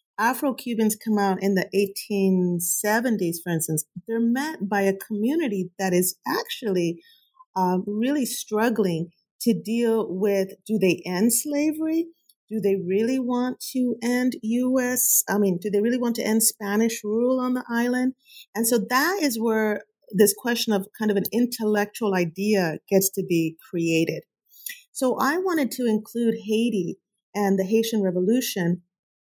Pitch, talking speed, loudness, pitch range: 220 Hz, 150 wpm, -24 LUFS, 195-245 Hz